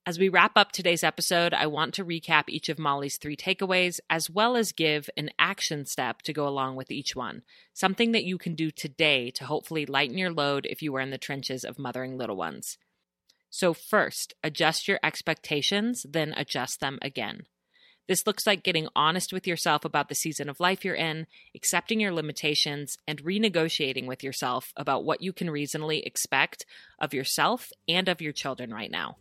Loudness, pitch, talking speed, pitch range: -27 LUFS, 155 Hz, 190 wpm, 145-180 Hz